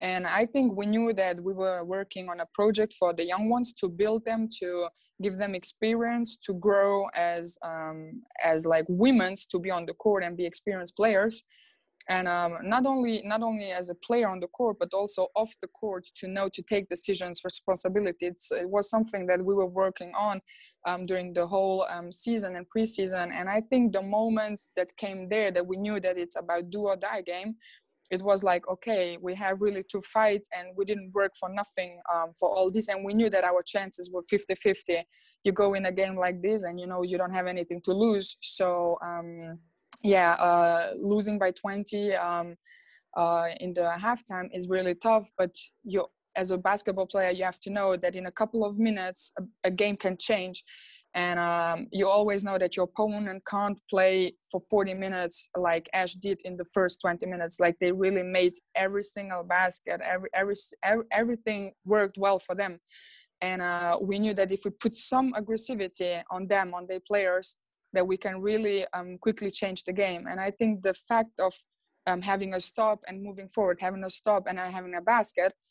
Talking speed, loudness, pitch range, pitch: 205 wpm, -28 LUFS, 180-205 Hz, 190 Hz